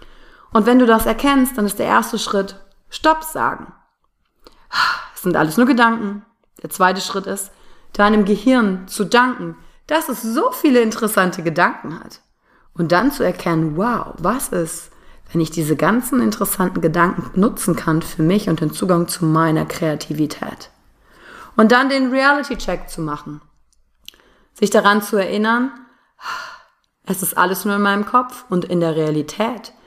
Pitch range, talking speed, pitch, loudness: 170-235 Hz, 155 wpm, 200 Hz, -17 LUFS